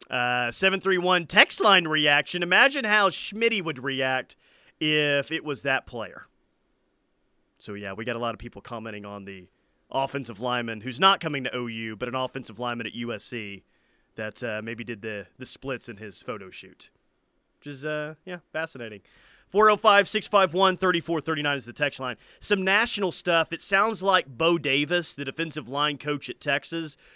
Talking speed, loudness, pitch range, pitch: 170 wpm, -24 LUFS, 120-175 Hz, 140 Hz